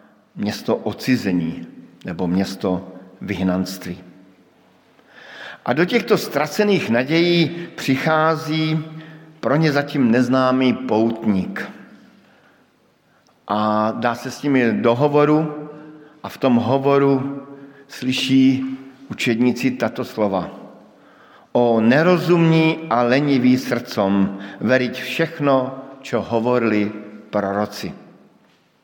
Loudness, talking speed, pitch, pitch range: -19 LUFS, 85 wpm, 130 Hz, 105-150 Hz